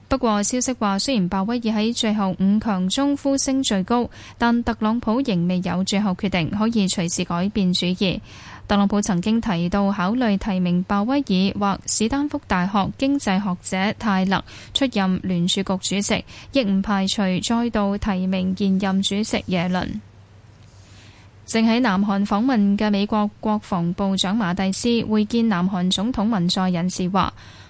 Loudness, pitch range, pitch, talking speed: -21 LUFS, 185-220 Hz, 200 Hz, 245 characters per minute